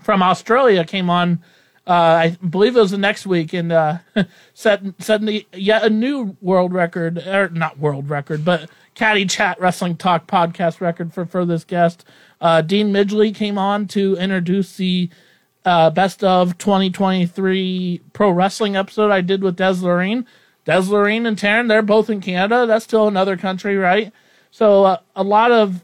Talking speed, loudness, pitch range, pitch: 170 wpm, -17 LUFS, 175-210 Hz, 190 Hz